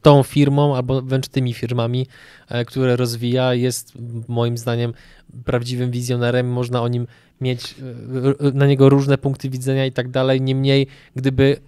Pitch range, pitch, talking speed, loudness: 125-135 Hz, 130 Hz, 140 wpm, -19 LUFS